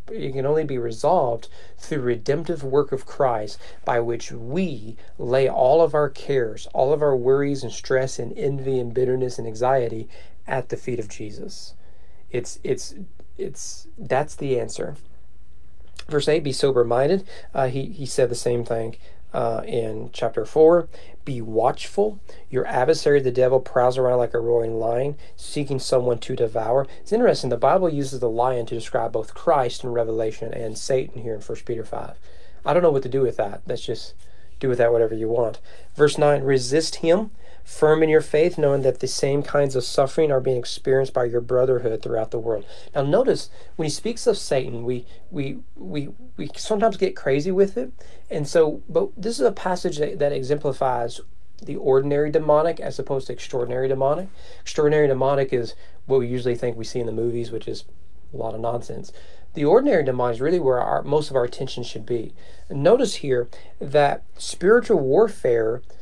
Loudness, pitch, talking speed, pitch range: -22 LUFS, 135 Hz, 185 wpm, 120-150 Hz